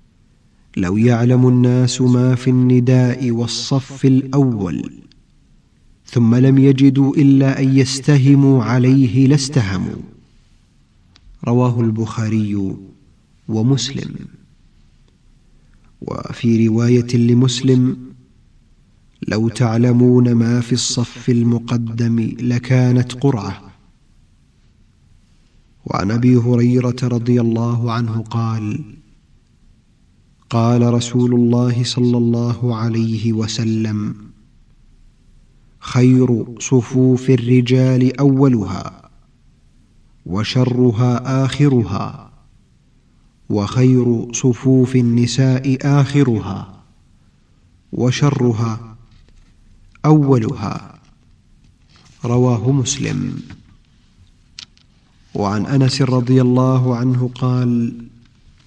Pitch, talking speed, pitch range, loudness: 125 Hz, 65 wpm, 115-130 Hz, -15 LUFS